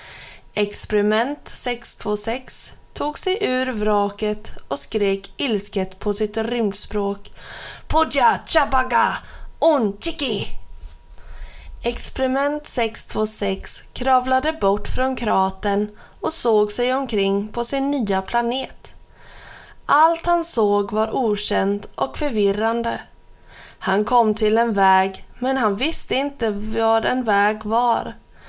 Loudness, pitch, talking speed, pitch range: -20 LUFS, 215 Hz, 105 wpm, 200-255 Hz